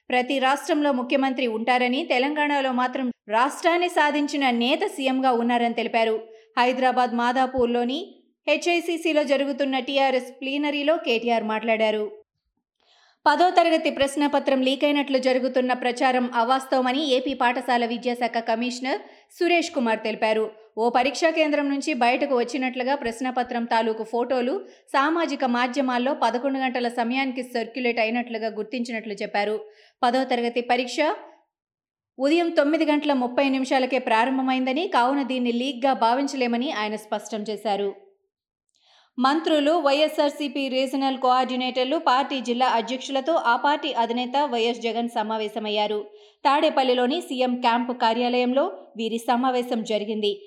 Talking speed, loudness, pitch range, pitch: 105 wpm, -23 LUFS, 235-280 Hz, 255 Hz